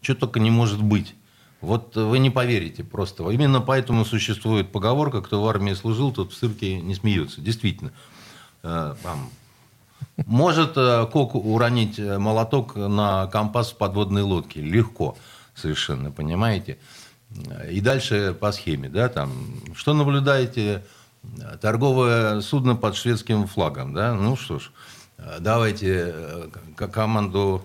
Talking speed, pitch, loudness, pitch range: 120 wpm, 110 Hz, -23 LUFS, 100-125 Hz